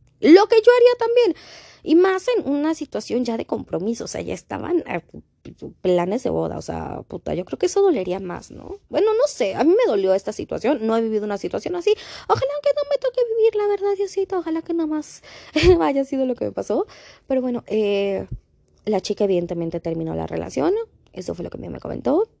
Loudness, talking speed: -21 LUFS, 220 wpm